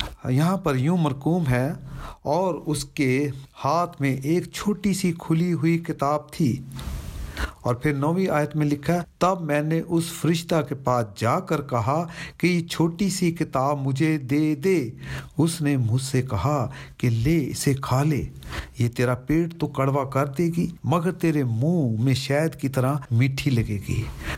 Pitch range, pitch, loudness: 130-165 Hz, 150 Hz, -24 LUFS